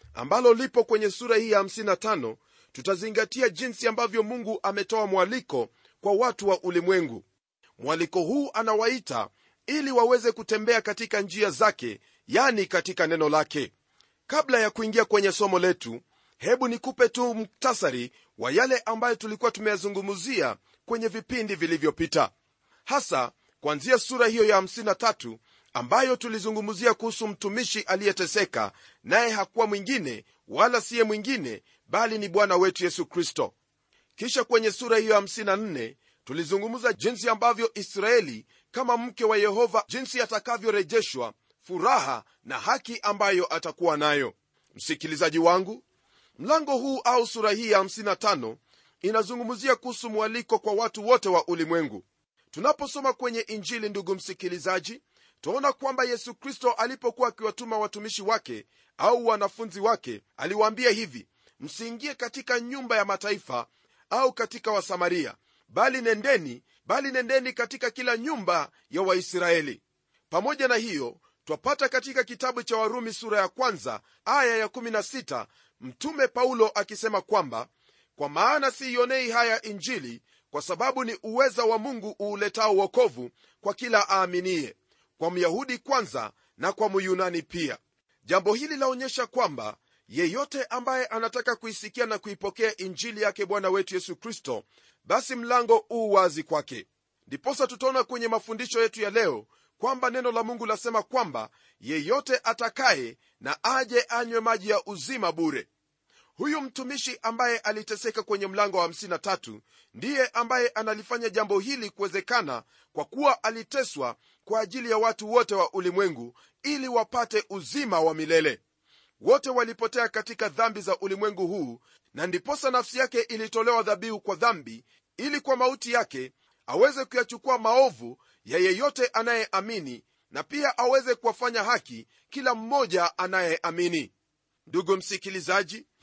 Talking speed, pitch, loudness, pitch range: 125 wpm, 225 Hz, -26 LUFS, 200-250 Hz